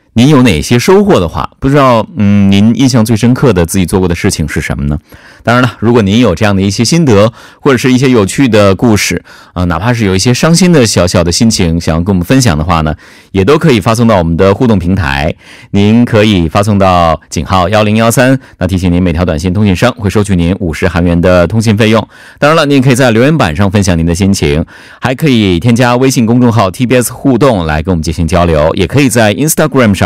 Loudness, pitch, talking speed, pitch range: -8 LUFS, 105 Hz, 370 characters per minute, 90-125 Hz